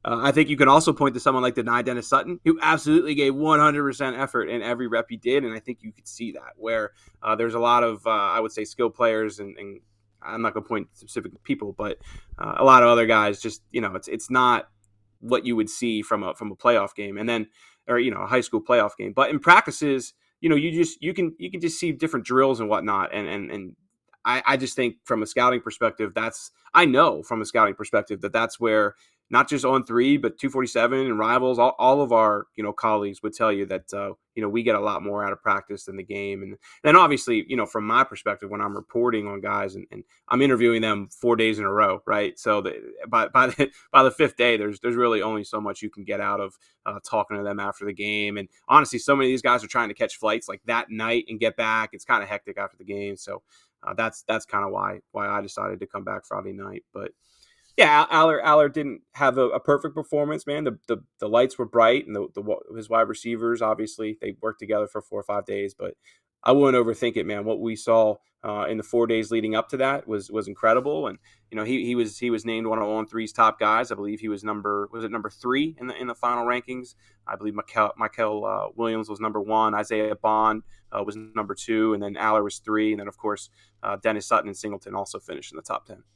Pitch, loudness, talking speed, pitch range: 115 Hz, -23 LUFS, 255 wpm, 105-130 Hz